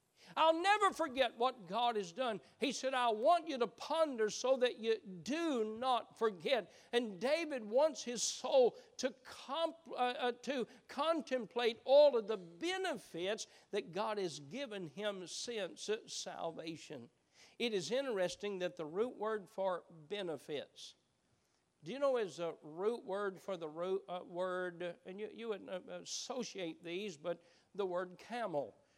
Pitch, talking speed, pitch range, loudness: 225 Hz, 150 wpm, 185-260 Hz, -38 LUFS